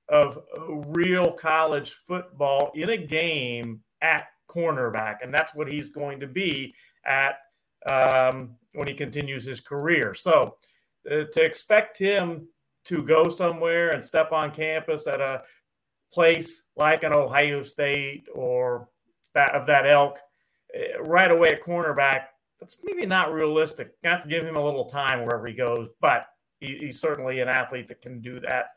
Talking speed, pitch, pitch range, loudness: 155 wpm, 145 Hz, 135-165 Hz, -24 LUFS